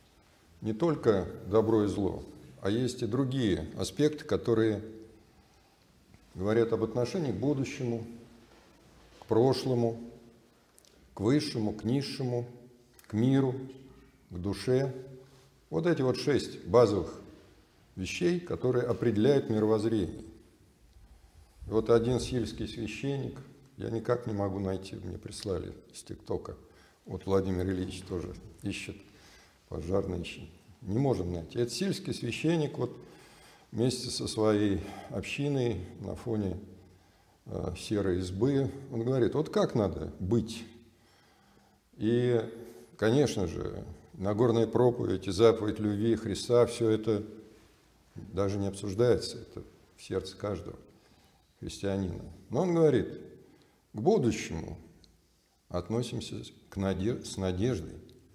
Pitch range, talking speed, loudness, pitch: 95-120 Hz, 110 wpm, -31 LUFS, 110 Hz